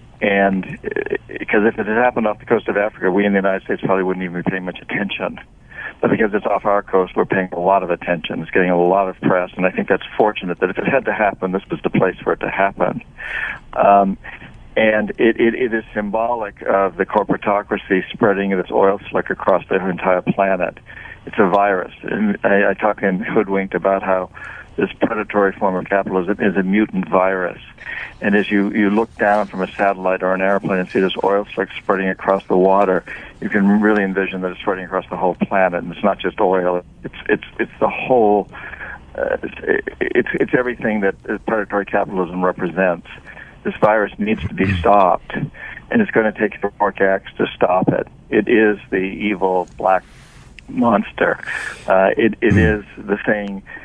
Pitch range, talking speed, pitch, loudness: 95-105 Hz, 200 wpm, 100 Hz, -18 LUFS